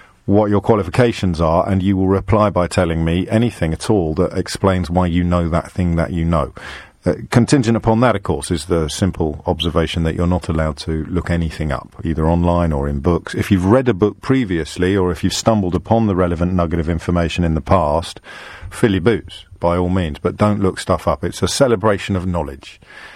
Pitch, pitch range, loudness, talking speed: 90 Hz, 85-100 Hz, -17 LUFS, 210 wpm